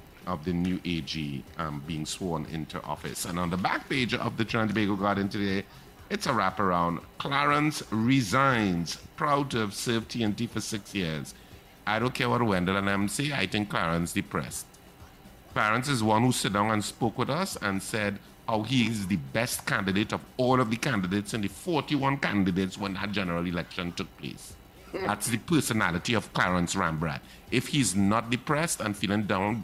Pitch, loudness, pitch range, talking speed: 105 Hz, -28 LUFS, 95-120 Hz, 180 wpm